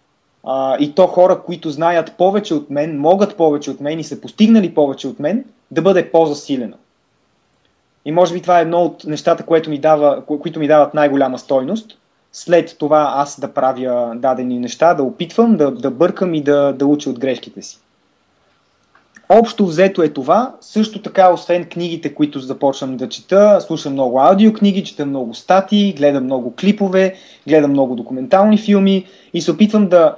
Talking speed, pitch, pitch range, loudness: 175 wpm, 160 Hz, 140-190 Hz, -15 LUFS